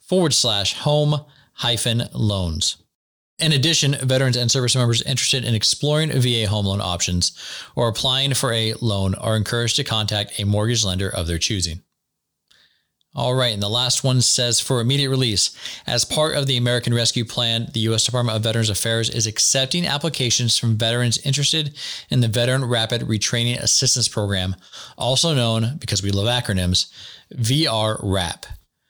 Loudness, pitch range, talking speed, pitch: -19 LUFS, 110-130 Hz, 160 wpm, 120 Hz